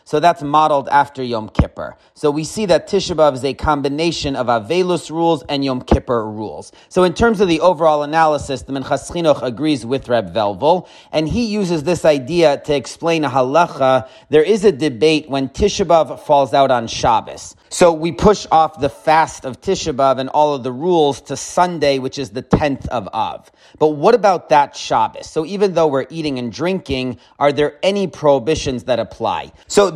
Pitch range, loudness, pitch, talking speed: 135-170 Hz, -16 LUFS, 150 Hz, 190 wpm